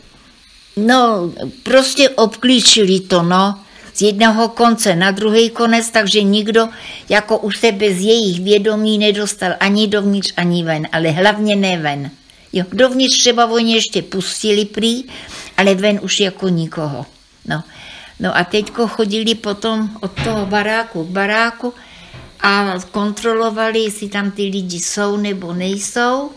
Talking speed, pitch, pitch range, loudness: 135 wpm, 210 Hz, 195-225 Hz, -14 LUFS